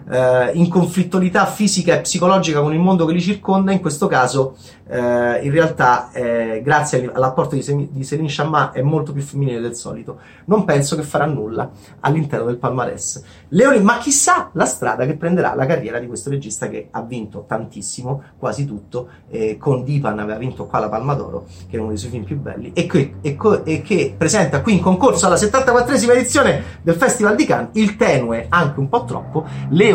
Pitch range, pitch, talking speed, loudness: 125-180 Hz, 145 Hz, 195 wpm, -17 LUFS